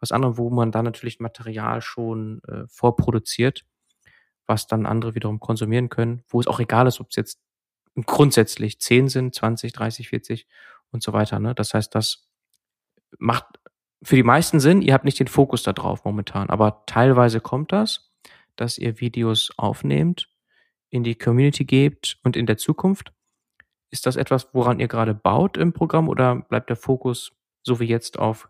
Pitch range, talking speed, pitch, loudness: 110-130 Hz, 175 wpm, 120 Hz, -21 LUFS